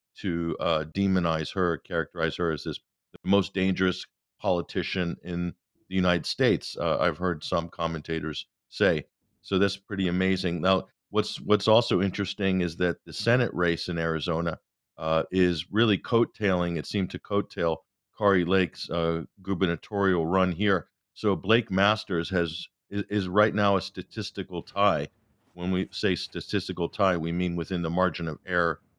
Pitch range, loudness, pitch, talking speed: 85-100 Hz, -27 LUFS, 90 Hz, 155 wpm